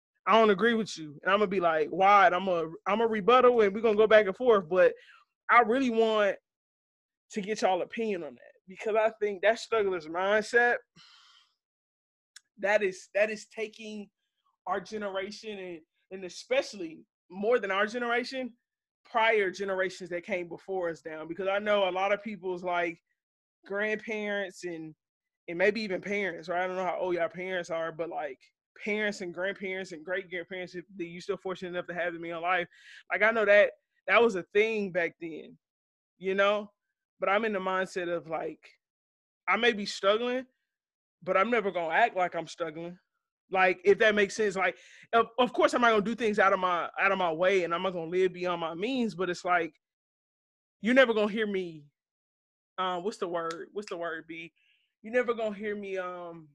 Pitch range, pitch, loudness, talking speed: 175-220 Hz, 195 Hz, -28 LUFS, 195 wpm